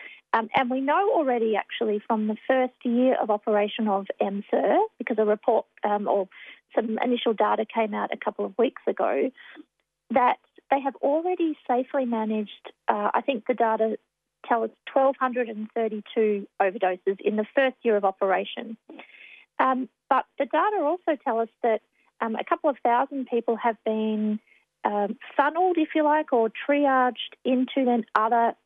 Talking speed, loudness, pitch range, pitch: 160 wpm, -25 LUFS, 215-275 Hz, 240 Hz